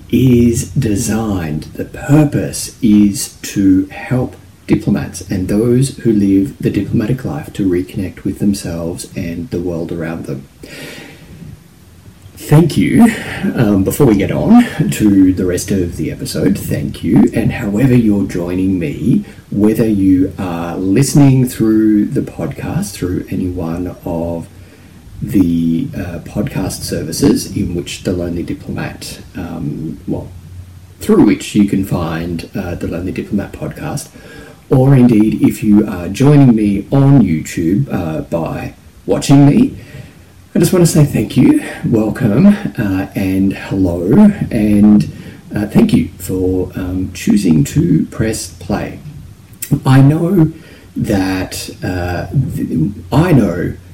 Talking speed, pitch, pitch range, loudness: 130 wpm, 100 Hz, 90-120 Hz, -14 LUFS